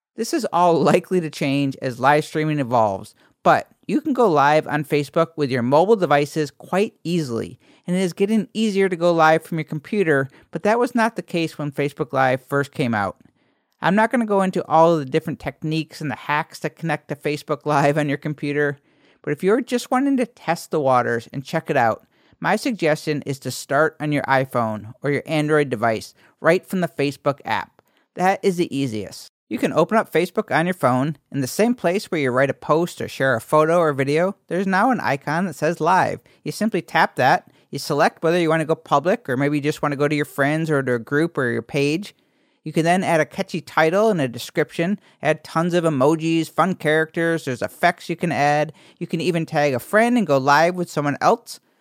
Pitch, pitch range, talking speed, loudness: 155 Hz, 145-175 Hz, 225 wpm, -20 LUFS